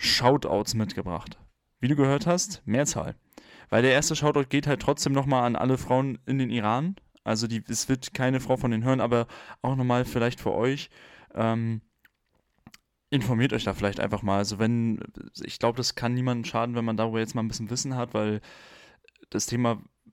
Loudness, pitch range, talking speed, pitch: -27 LUFS, 115-130 Hz, 190 wpm, 120 Hz